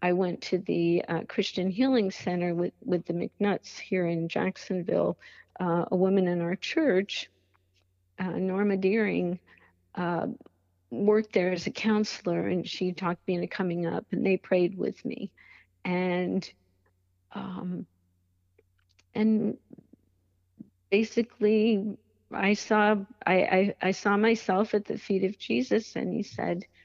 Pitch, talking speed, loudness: 180 Hz, 135 wpm, -28 LUFS